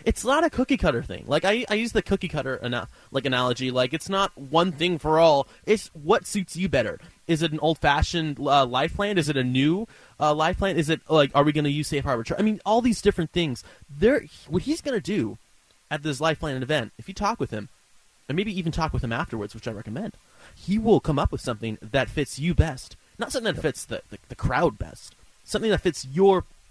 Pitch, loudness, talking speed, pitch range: 155 Hz, -24 LUFS, 245 wpm, 135-195 Hz